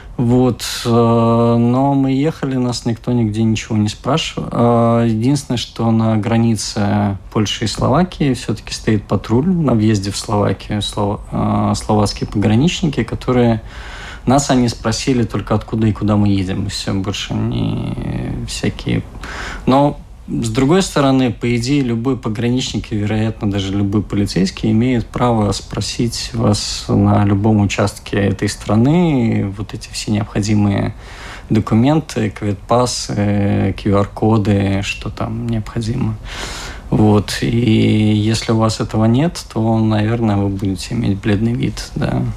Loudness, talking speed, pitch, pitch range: -16 LUFS, 125 wpm, 110 Hz, 105-120 Hz